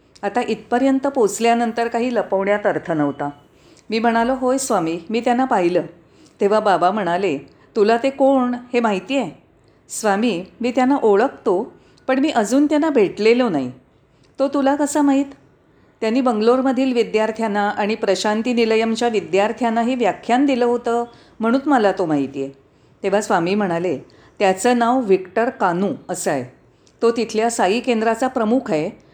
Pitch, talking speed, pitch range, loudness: 230 Hz, 140 wpm, 195-250 Hz, -19 LUFS